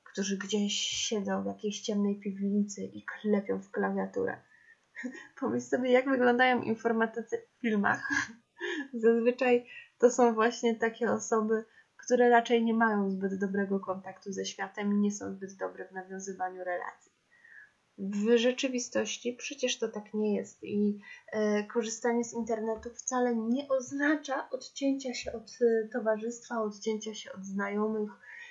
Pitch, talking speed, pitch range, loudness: 225 Hz, 135 wpm, 205-245 Hz, -31 LUFS